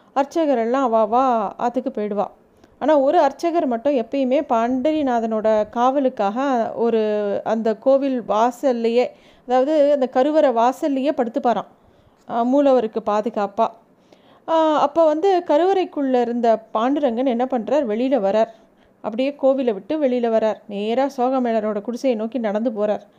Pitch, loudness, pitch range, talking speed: 250 Hz, -20 LUFS, 225-275 Hz, 115 wpm